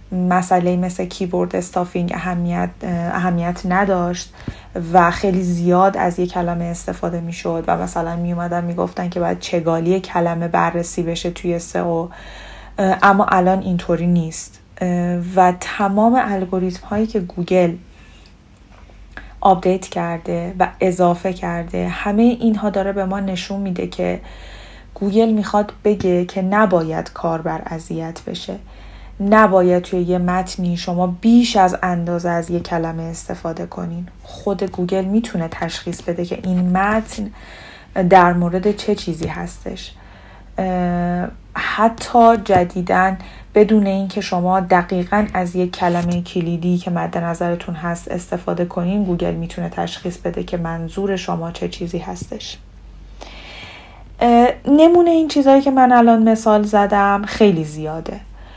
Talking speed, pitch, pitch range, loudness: 130 wpm, 180 Hz, 170-195 Hz, -18 LUFS